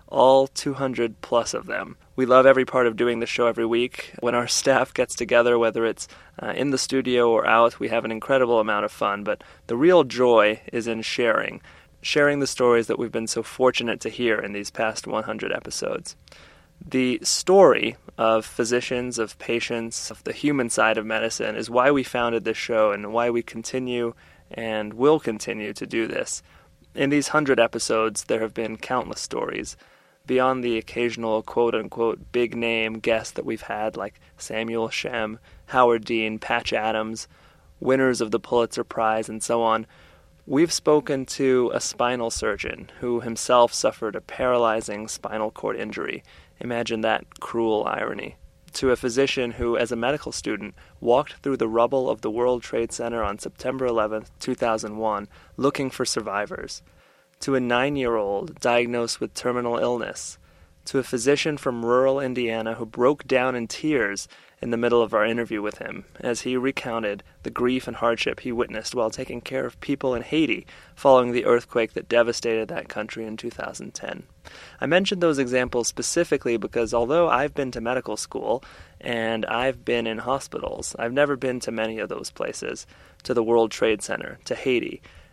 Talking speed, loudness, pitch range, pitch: 175 wpm, -23 LUFS, 110-130 Hz, 120 Hz